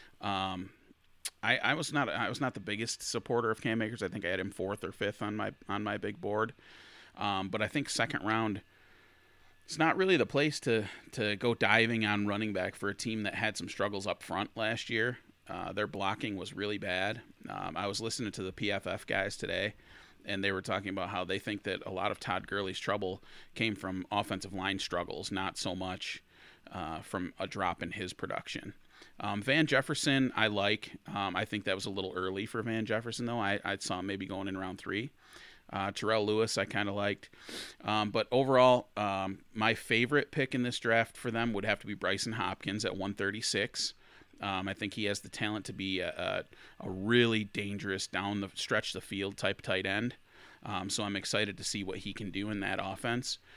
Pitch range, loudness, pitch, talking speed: 95-115 Hz, -33 LUFS, 105 Hz, 210 wpm